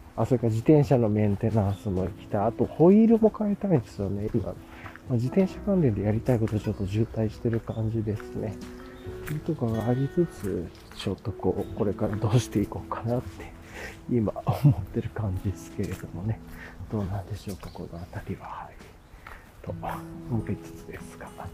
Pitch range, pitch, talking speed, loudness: 95-125 Hz, 110 Hz, 375 characters per minute, -27 LUFS